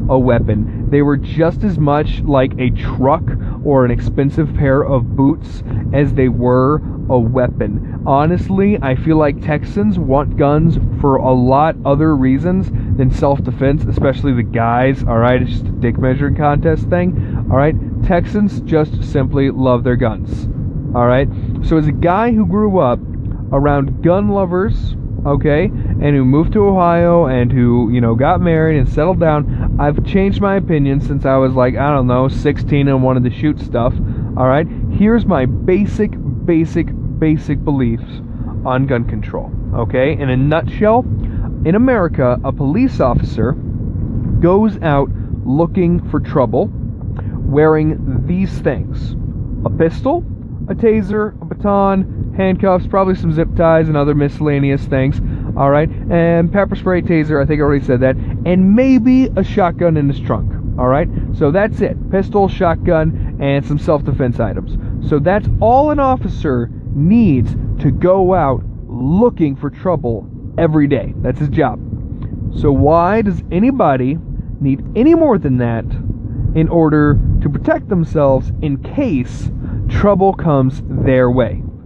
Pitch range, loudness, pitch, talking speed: 120-160 Hz, -14 LUFS, 135 Hz, 155 wpm